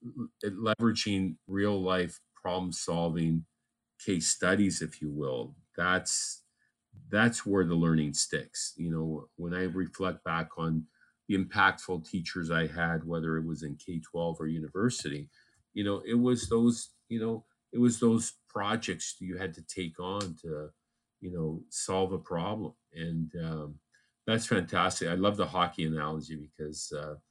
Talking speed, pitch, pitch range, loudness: 150 wpm, 85 Hz, 80-100 Hz, -32 LUFS